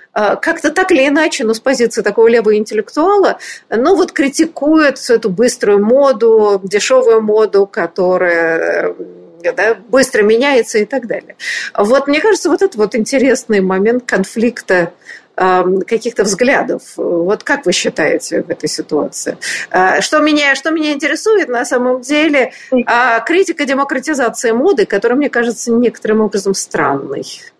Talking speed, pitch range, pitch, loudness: 135 wpm, 215-285 Hz, 235 Hz, -13 LUFS